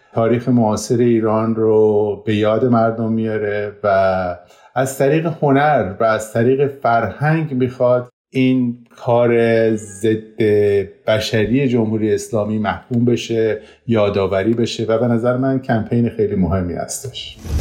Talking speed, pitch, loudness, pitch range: 120 wpm, 115 Hz, -17 LUFS, 105-125 Hz